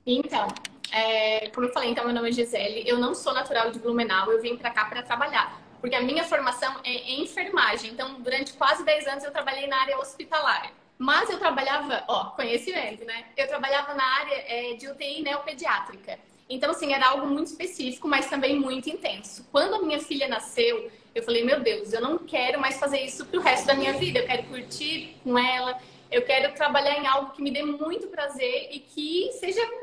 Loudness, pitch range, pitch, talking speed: -26 LUFS, 245-305 Hz, 275 Hz, 205 wpm